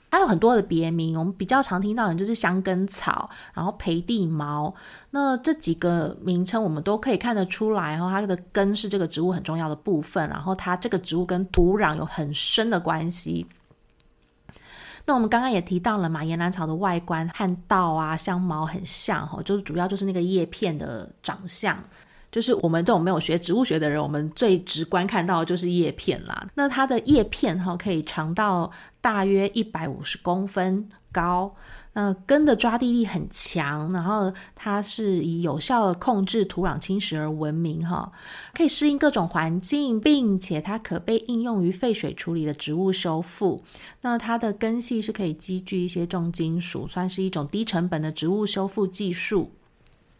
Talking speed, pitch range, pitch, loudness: 280 characters per minute, 165-210 Hz, 185 Hz, -24 LUFS